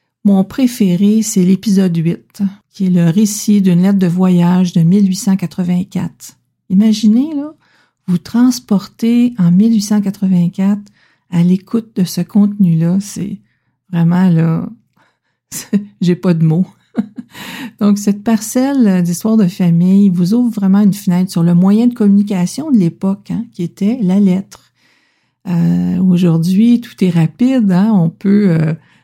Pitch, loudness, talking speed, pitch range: 195 Hz, -13 LUFS, 135 wpm, 180-215 Hz